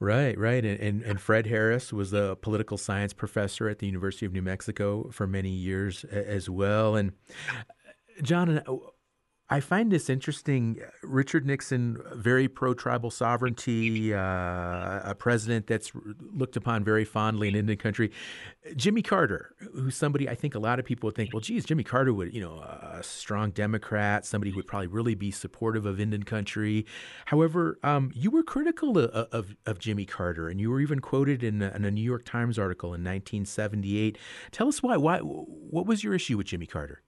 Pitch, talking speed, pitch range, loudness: 110 Hz, 190 wpm, 100-130 Hz, -29 LUFS